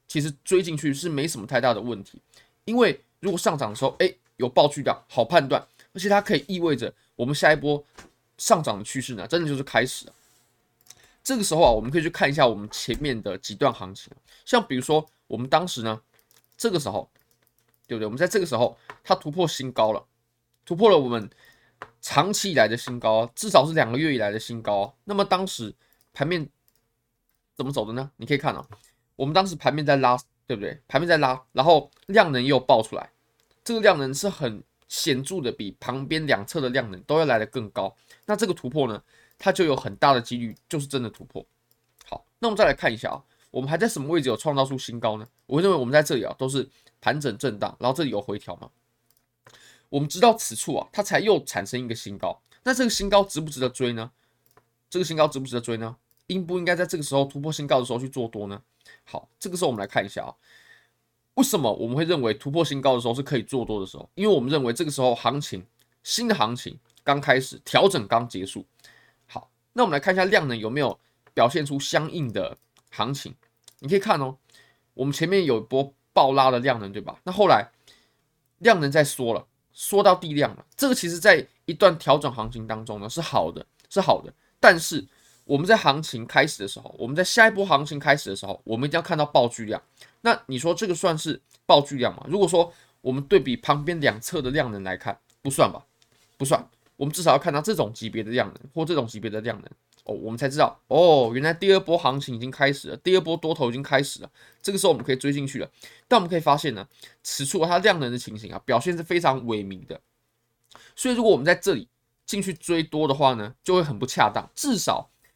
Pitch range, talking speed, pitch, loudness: 115-170 Hz, 325 characters per minute, 135 Hz, -23 LUFS